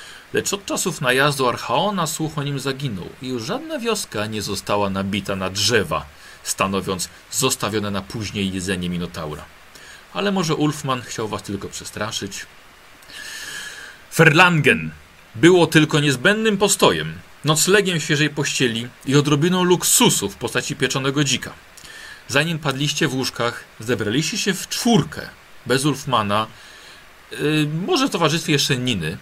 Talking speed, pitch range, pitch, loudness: 125 wpm, 105-160 Hz, 135 Hz, -19 LUFS